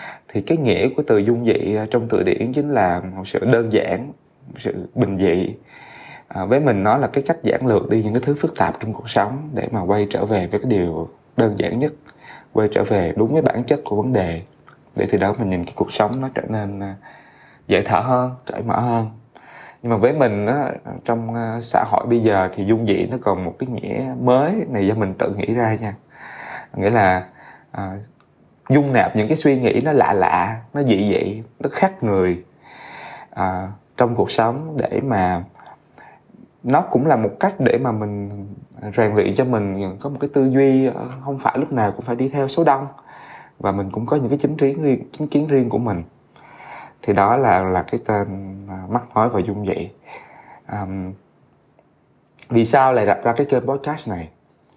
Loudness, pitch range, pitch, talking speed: -19 LUFS, 100-130 Hz, 115 Hz, 205 wpm